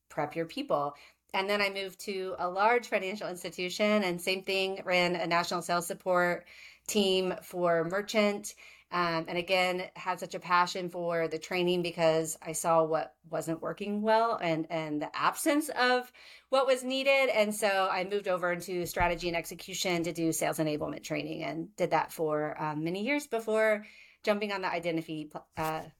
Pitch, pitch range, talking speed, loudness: 180 Hz, 165-205 Hz, 175 wpm, -30 LUFS